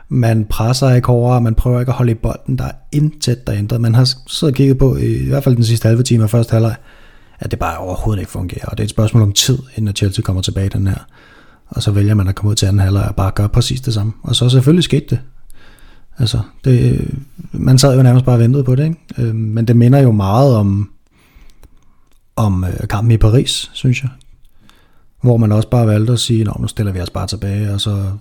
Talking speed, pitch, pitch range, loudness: 240 wpm, 115 Hz, 105-130 Hz, -14 LUFS